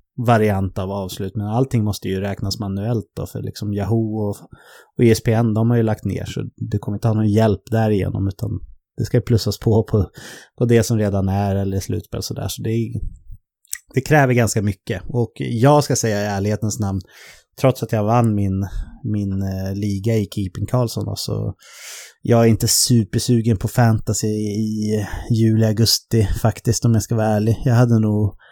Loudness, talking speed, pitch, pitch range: -19 LUFS, 185 wpm, 110 Hz, 100-115 Hz